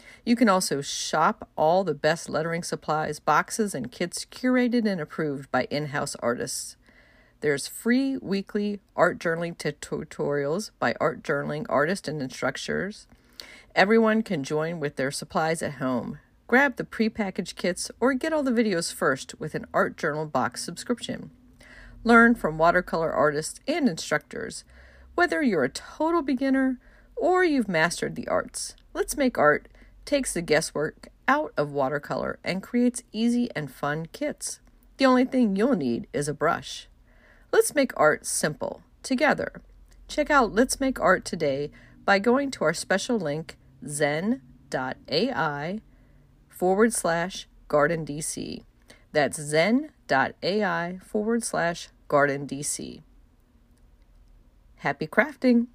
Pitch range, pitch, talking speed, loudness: 150-245 Hz, 185 Hz, 130 wpm, -25 LUFS